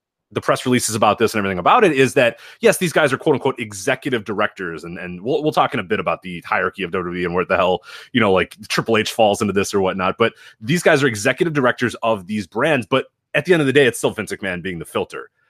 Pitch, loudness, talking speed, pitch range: 125 Hz, -18 LUFS, 265 wpm, 105-145 Hz